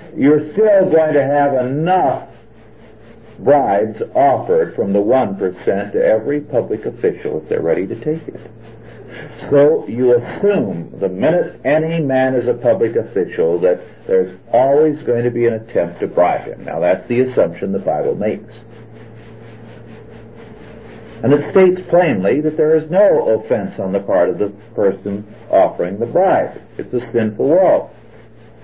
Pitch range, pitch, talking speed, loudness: 115-180 Hz, 130 Hz, 150 wpm, -16 LUFS